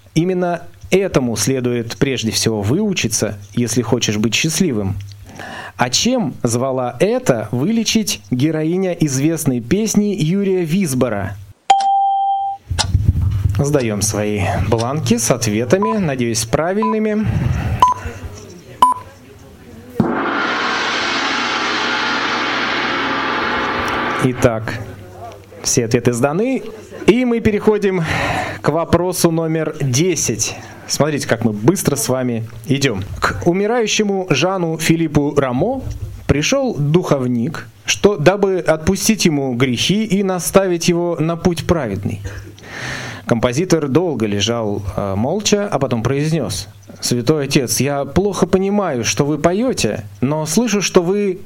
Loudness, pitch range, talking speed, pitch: -17 LUFS, 115-185 Hz, 95 wpm, 145 Hz